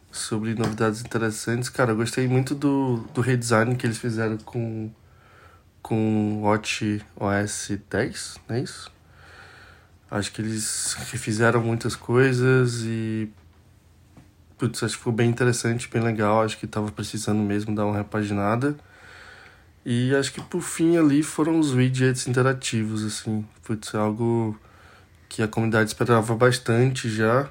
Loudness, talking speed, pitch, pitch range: -24 LUFS, 140 wpm, 110 Hz, 105-125 Hz